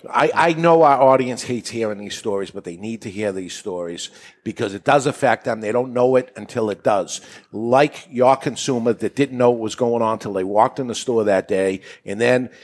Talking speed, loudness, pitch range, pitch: 235 wpm, -19 LUFS, 105-130 Hz, 120 Hz